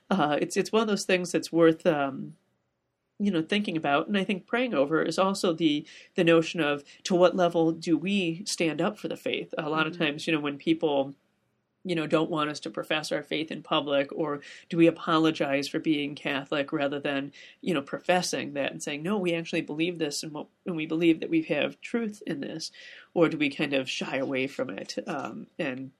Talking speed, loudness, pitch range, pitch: 215 wpm, -28 LUFS, 150-180 Hz, 165 Hz